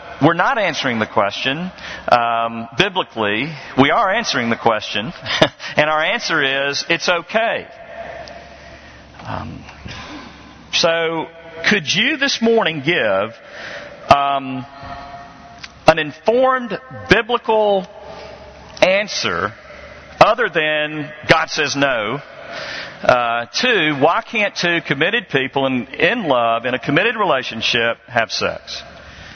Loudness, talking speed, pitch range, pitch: -17 LUFS, 105 wpm, 130-200 Hz, 155 Hz